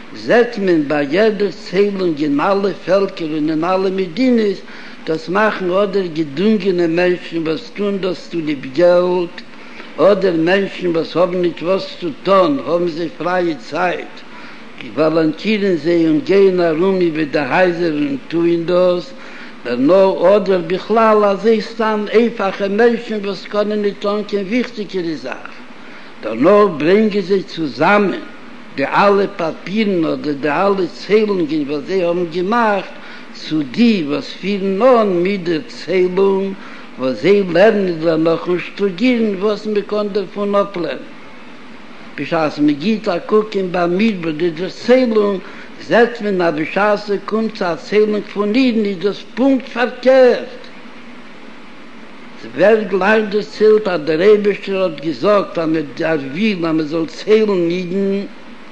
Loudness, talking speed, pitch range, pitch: -16 LUFS, 145 wpm, 175-220 Hz, 200 Hz